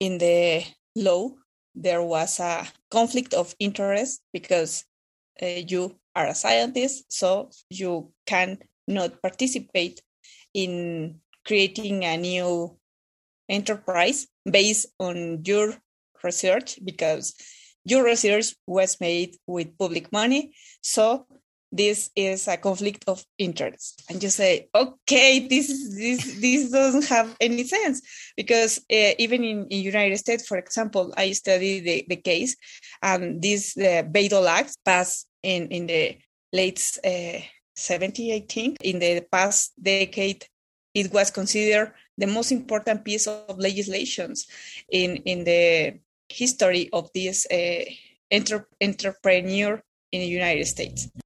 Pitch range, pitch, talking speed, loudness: 180-230 Hz, 195 Hz, 125 wpm, -23 LUFS